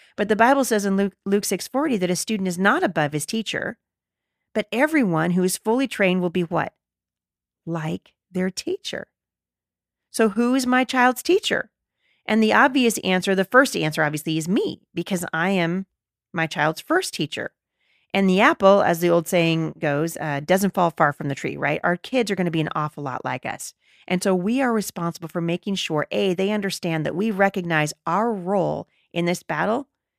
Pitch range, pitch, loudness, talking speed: 165-220 Hz, 185 Hz, -22 LUFS, 190 wpm